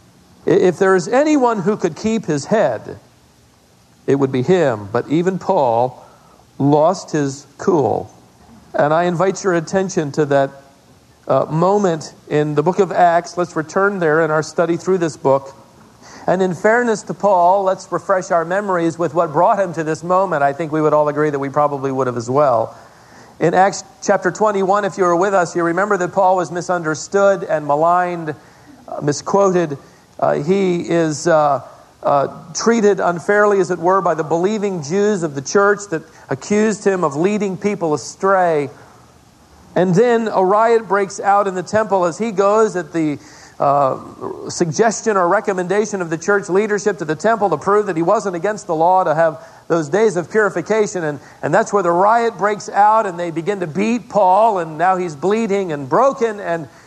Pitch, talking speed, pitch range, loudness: 180 Hz, 185 wpm, 155-200 Hz, -17 LUFS